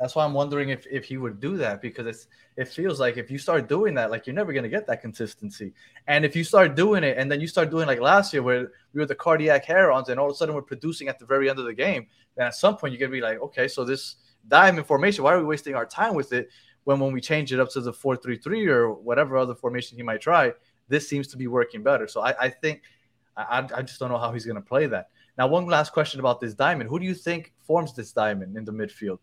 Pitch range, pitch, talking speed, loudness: 120-155 Hz, 135 Hz, 285 wpm, -24 LUFS